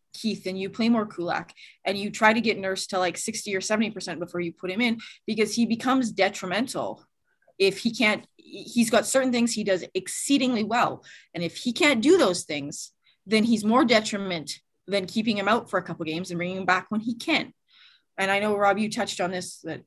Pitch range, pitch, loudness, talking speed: 185-230 Hz, 210 Hz, -25 LUFS, 225 wpm